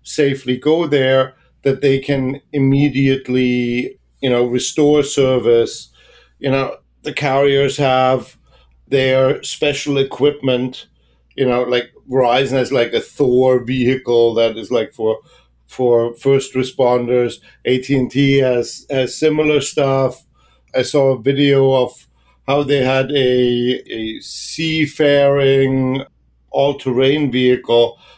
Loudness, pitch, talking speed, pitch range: -16 LUFS, 130 Hz, 115 wpm, 125-140 Hz